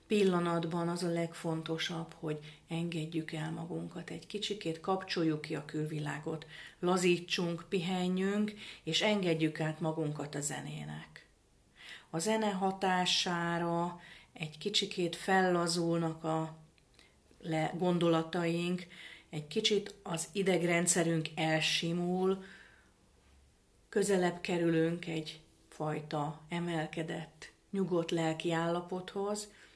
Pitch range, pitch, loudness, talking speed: 160-180 Hz, 170 Hz, -34 LUFS, 85 wpm